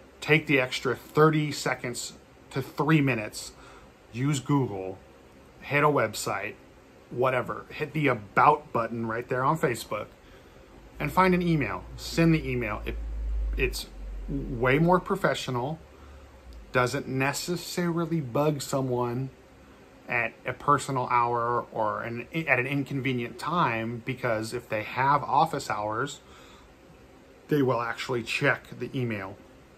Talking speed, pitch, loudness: 120 wpm, 125 Hz, -27 LUFS